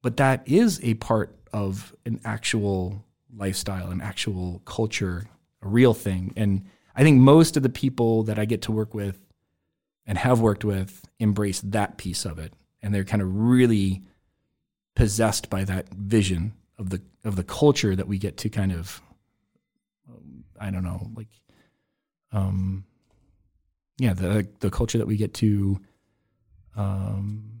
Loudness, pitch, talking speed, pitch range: -24 LUFS, 105 Hz, 155 wpm, 95-115 Hz